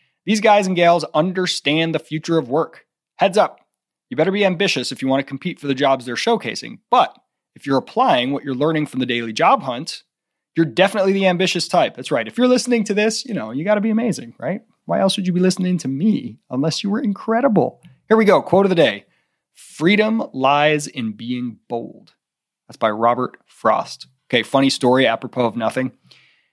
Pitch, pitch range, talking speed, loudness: 160 Hz, 130-200 Hz, 205 wpm, -18 LUFS